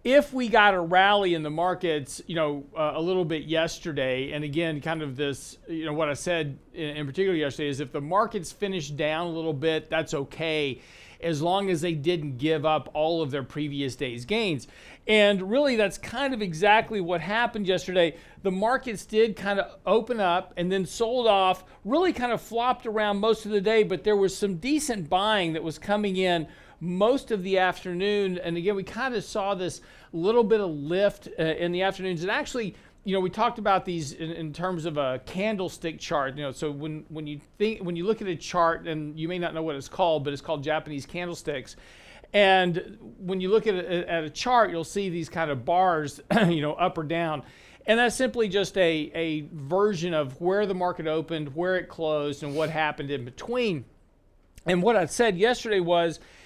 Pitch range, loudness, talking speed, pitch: 155-205 Hz, -26 LUFS, 210 wpm, 175 Hz